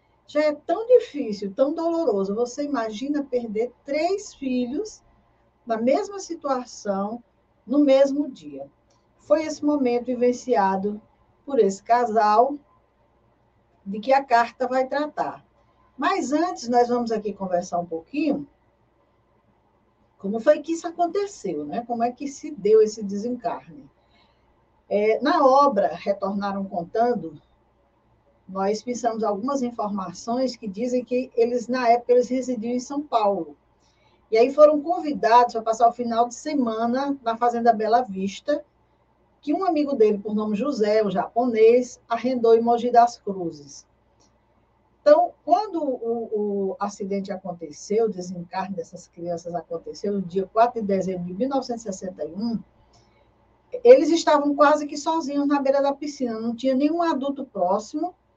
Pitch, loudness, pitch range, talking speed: 235 Hz, -23 LUFS, 195-280 Hz, 135 wpm